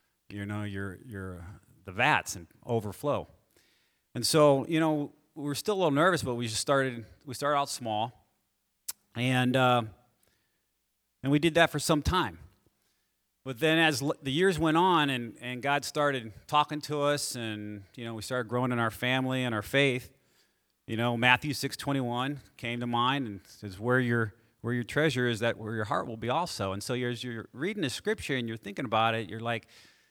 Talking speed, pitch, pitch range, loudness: 200 wpm, 125 Hz, 110-145 Hz, -29 LUFS